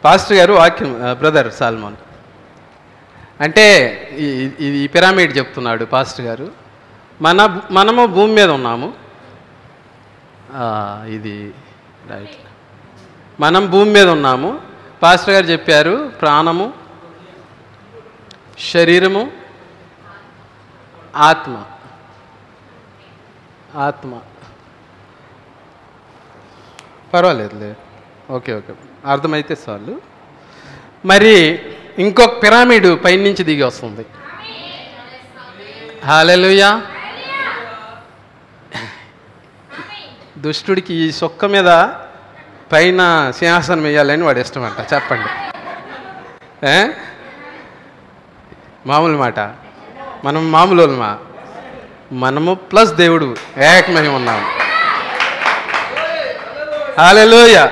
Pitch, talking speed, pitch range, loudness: 150 Hz, 65 wpm, 120-185 Hz, -11 LUFS